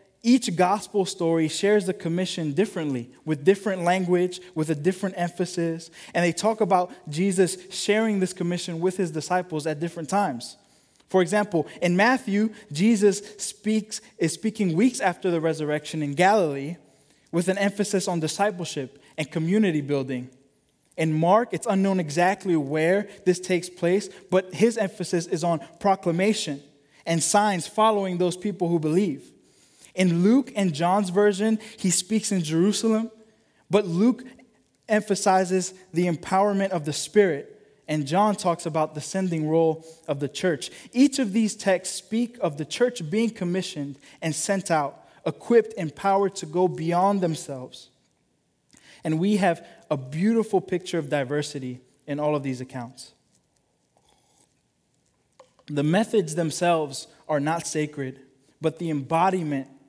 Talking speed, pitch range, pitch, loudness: 140 wpm, 160-200 Hz, 180 Hz, -24 LUFS